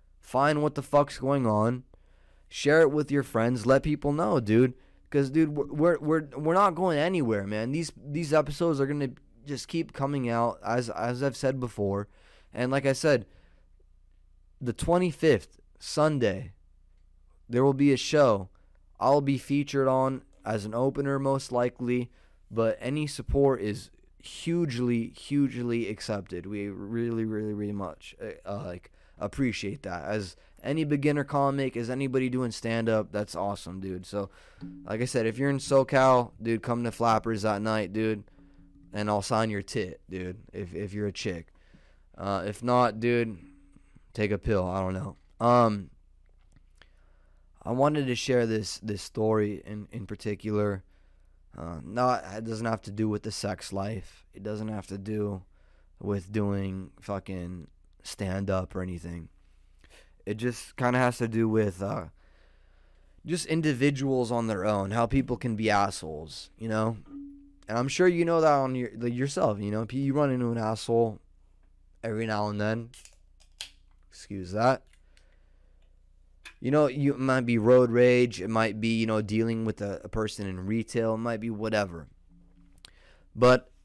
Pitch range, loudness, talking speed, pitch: 95-130 Hz, -28 LUFS, 165 wpm, 110 Hz